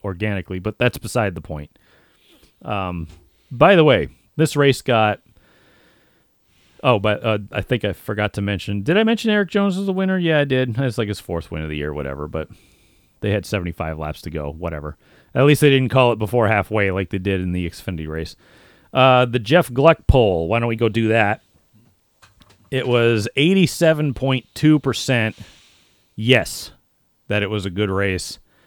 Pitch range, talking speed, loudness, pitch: 95-130 Hz, 180 wpm, -19 LUFS, 105 Hz